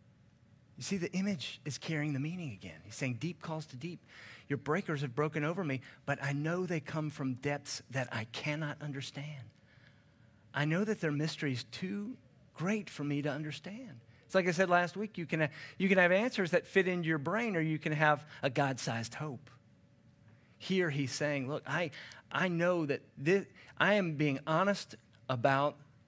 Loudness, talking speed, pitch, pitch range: -34 LUFS, 195 wpm, 150 Hz, 135-175 Hz